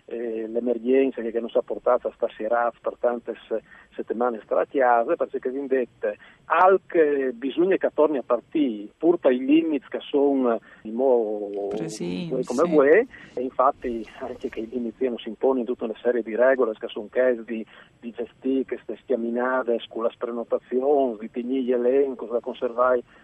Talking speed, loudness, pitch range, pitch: 170 wpm, -24 LUFS, 115-135 Hz, 125 Hz